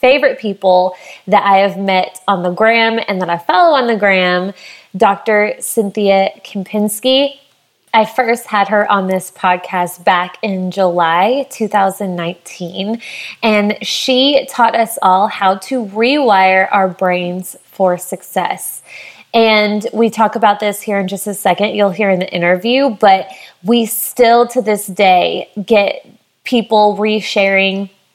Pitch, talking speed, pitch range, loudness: 205 Hz, 140 wpm, 190-225 Hz, -13 LUFS